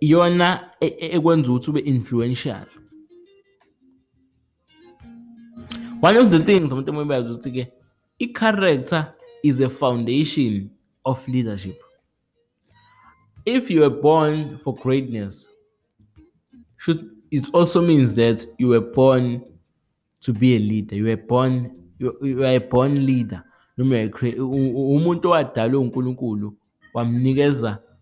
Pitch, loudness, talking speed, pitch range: 130 Hz, -20 LUFS, 95 wpm, 120-165 Hz